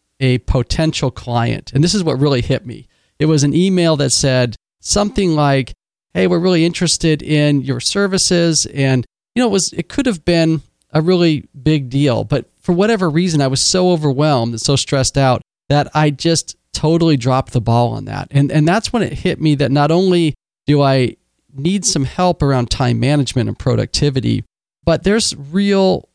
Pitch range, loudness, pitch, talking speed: 130-170 Hz, -15 LUFS, 145 Hz, 195 wpm